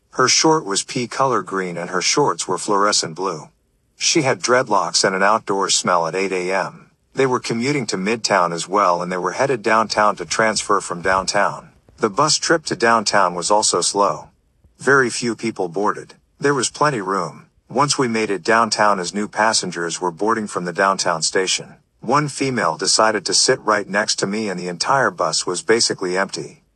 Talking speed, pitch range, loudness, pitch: 190 wpm, 90-115 Hz, -18 LUFS, 105 Hz